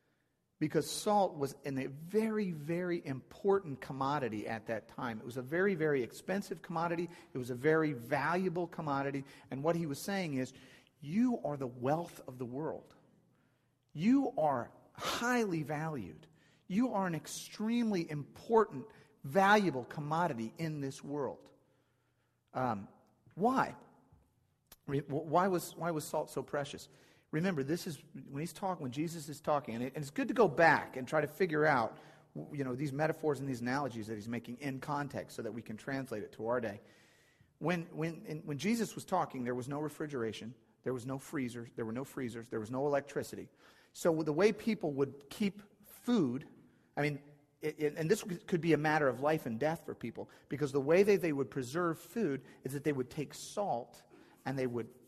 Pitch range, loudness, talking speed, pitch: 130-170 Hz, -36 LUFS, 185 wpm, 150 Hz